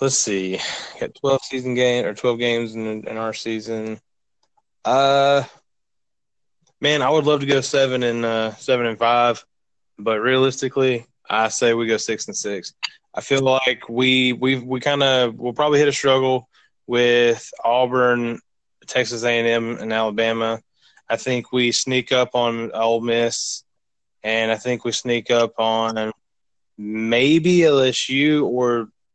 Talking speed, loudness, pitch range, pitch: 155 wpm, -20 LUFS, 115-130 Hz, 120 Hz